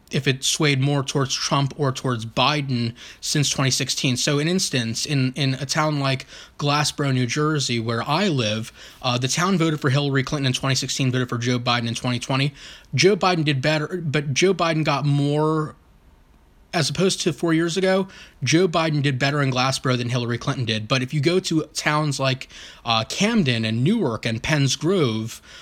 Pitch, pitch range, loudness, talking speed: 140 Hz, 125-155 Hz, -21 LUFS, 190 wpm